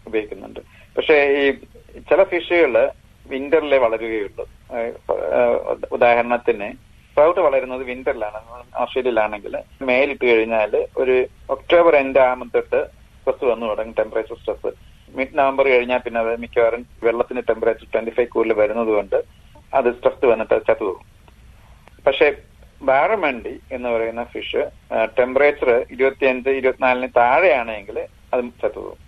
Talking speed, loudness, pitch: 110 wpm, -19 LUFS, 140 Hz